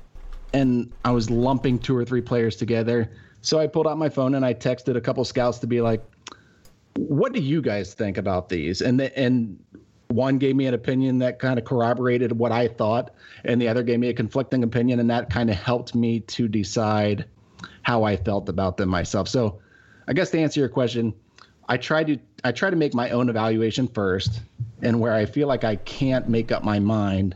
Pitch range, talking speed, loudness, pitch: 110-130 Hz, 215 wpm, -23 LUFS, 120 Hz